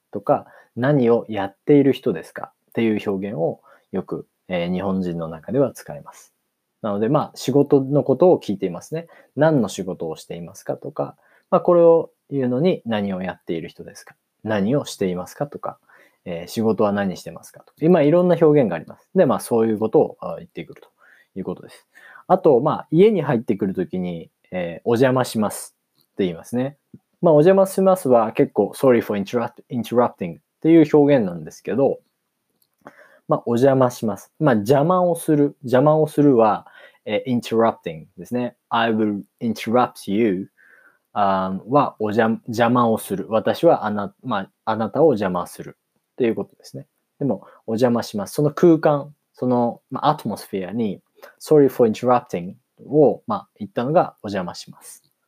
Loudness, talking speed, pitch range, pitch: -20 LUFS, 385 characters per minute, 105-150 Hz, 120 Hz